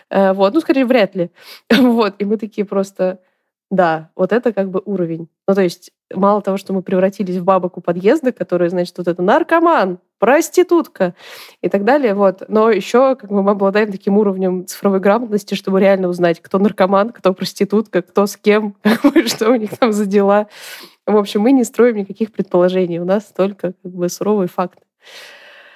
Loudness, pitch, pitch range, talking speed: -16 LUFS, 200 Hz, 185-220 Hz, 180 wpm